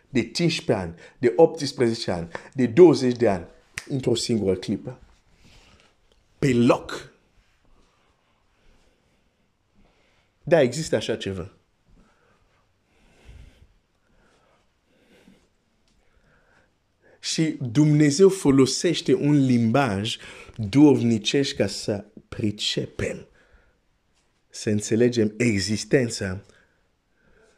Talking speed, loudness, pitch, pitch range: 70 wpm, -22 LUFS, 120 Hz, 105-140 Hz